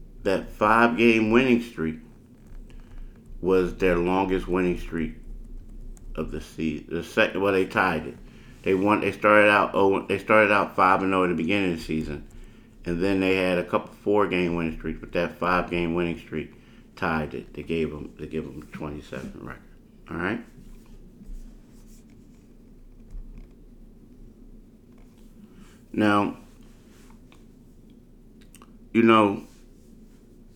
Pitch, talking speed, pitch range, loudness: 90 Hz, 130 wpm, 80-100 Hz, -24 LUFS